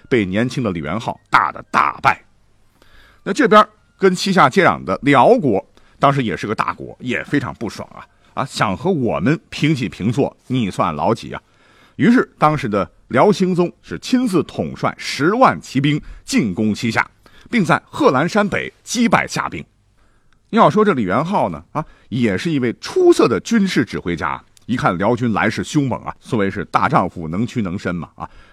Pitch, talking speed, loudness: 145 Hz, 255 characters per minute, -17 LUFS